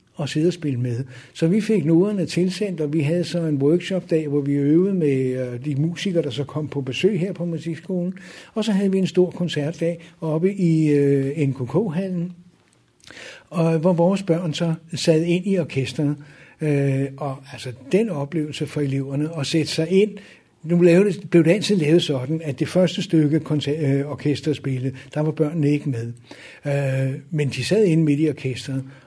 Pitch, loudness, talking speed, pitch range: 155 Hz, -21 LUFS, 175 wpm, 140-175 Hz